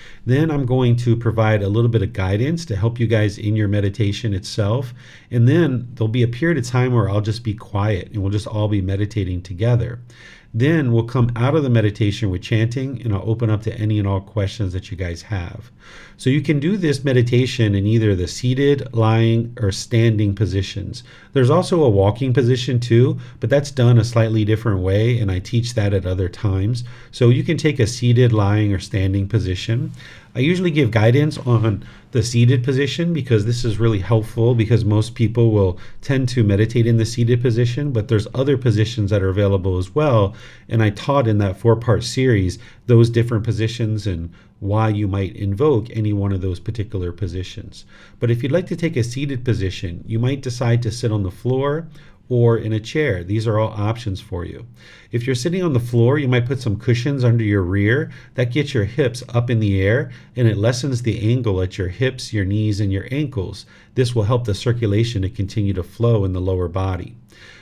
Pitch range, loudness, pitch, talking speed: 105-125 Hz, -19 LUFS, 115 Hz, 210 wpm